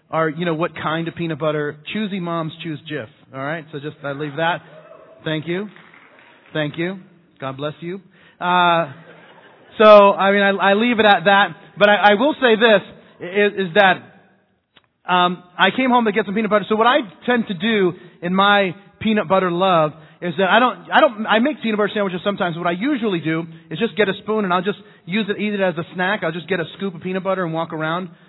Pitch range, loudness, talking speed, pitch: 165-205 Hz, -18 LUFS, 225 wpm, 185 Hz